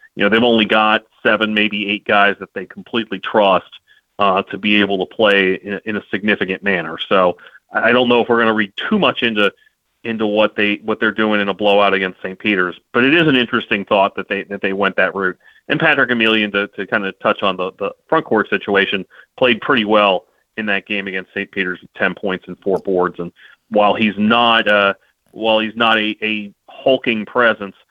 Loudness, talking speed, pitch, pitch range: -16 LUFS, 220 wpm, 105 Hz, 100-110 Hz